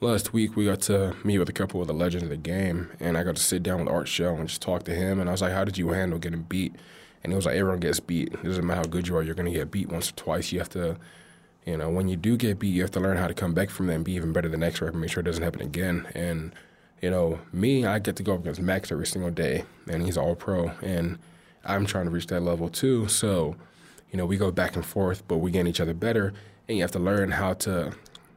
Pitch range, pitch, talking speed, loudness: 85-95 Hz, 90 Hz, 300 wpm, -27 LUFS